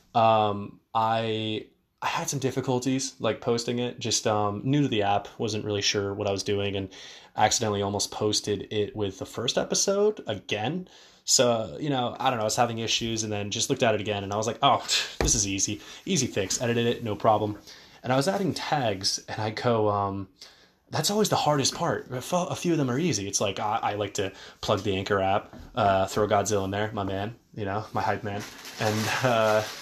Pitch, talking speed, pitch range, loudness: 110 Hz, 215 wpm, 105-130 Hz, -26 LUFS